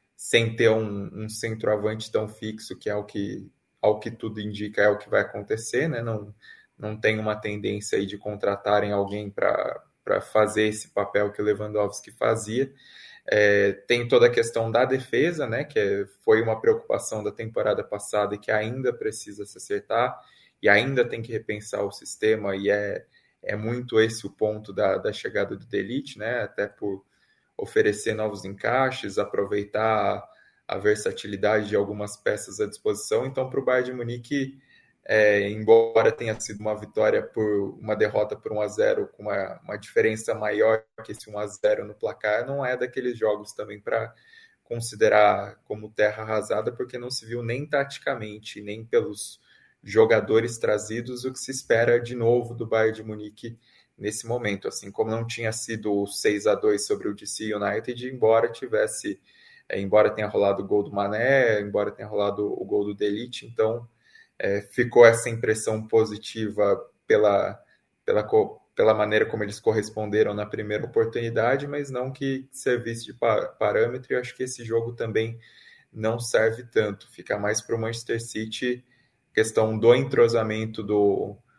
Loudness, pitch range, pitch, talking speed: -25 LUFS, 105-130 Hz, 115 Hz, 165 wpm